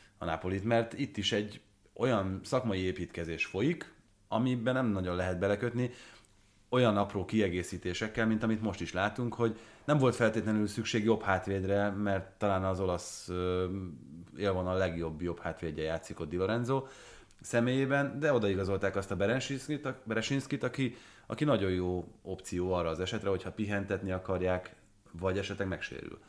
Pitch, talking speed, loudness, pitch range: 100 Hz, 150 wpm, -33 LUFS, 90-115 Hz